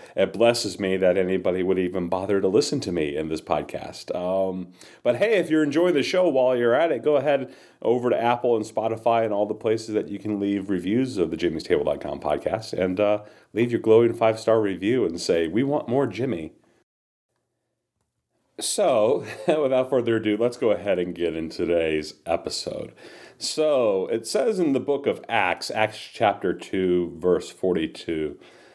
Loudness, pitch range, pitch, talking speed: -23 LUFS, 95-120 Hz, 105 Hz, 180 wpm